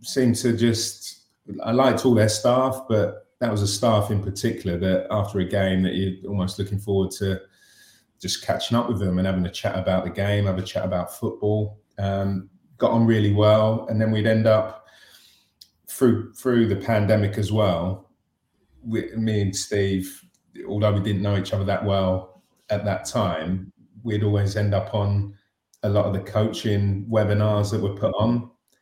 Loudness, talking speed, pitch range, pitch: -23 LUFS, 185 wpm, 95-110 Hz, 105 Hz